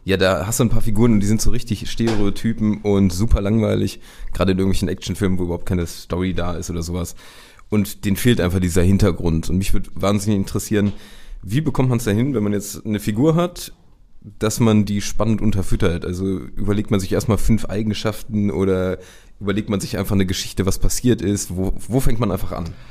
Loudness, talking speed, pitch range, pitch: -20 LUFS, 205 wpm, 95-110 Hz, 100 Hz